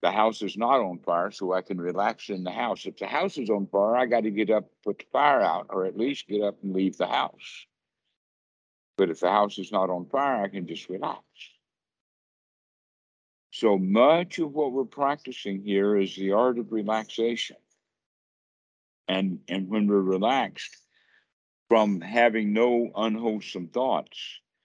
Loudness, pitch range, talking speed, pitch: -26 LUFS, 95-115 Hz, 175 wpm, 105 Hz